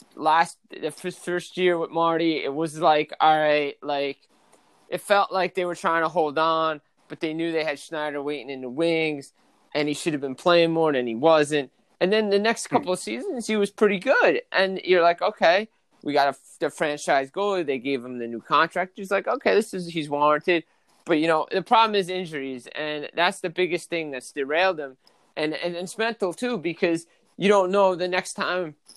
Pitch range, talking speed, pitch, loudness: 150-185 Hz, 210 wpm, 165 Hz, -24 LUFS